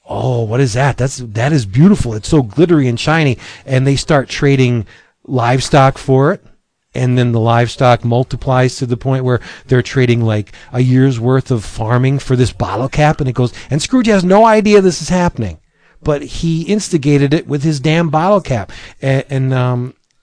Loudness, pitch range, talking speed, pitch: -13 LUFS, 120-150 Hz, 190 wpm, 130 Hz